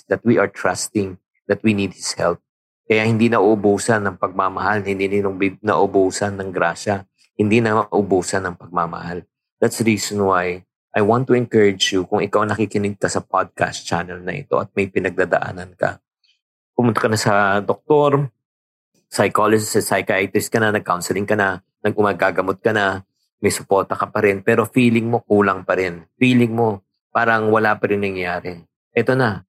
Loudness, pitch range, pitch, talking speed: -19 LUFS, 95-110 Hz, 100 Hz, 165 wpm